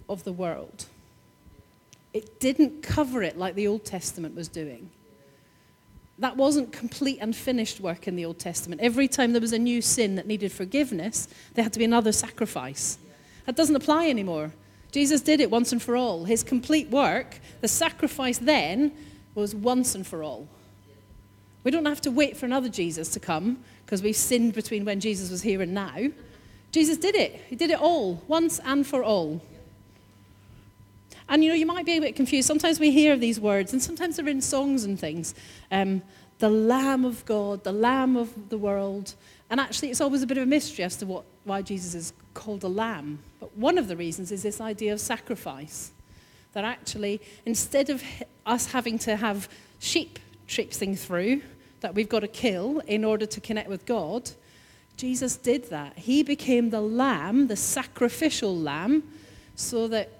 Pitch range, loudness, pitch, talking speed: 195-270 Hz, -26 LUFS, 230 Hz, 185 wpm